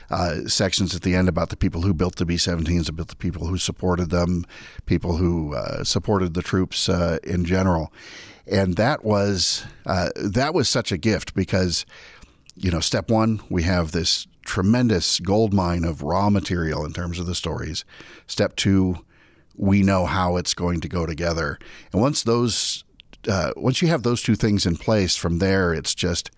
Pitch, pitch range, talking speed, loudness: 90 Hz, 85-100 Hz, 185 wpm, -22 LUFS